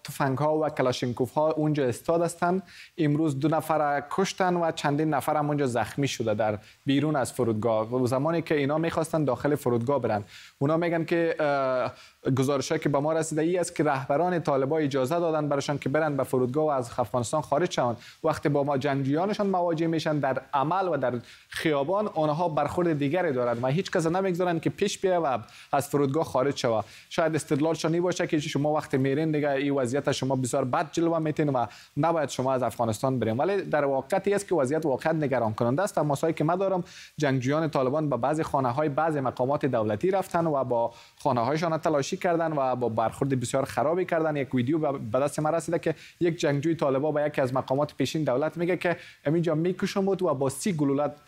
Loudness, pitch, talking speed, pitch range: -27 LUFS, 150 Hz, 190 wpm, 135-165 Hz